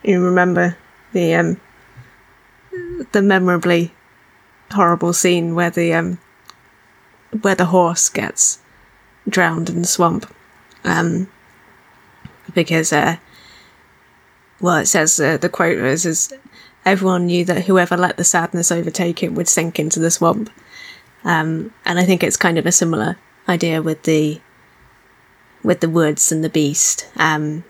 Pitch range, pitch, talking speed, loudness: 165-180 Hz, 175 Hz, 140 wpm, -16 LUFS